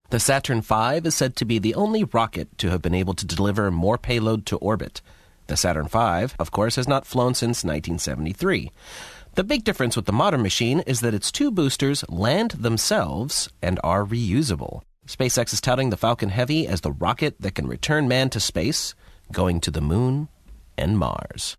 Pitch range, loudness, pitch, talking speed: 95-130 Hz, -23 LUFS, 115 Hz, 190 wpm